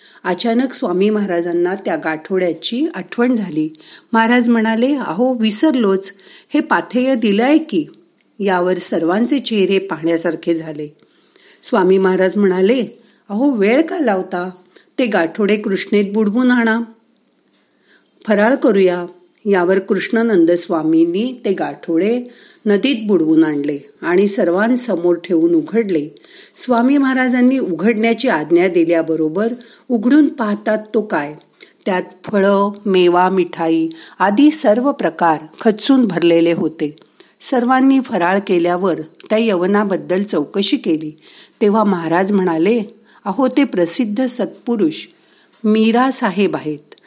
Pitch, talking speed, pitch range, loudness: 205 Hz, 105 wpm, 175-240 Hz, -16 LUFS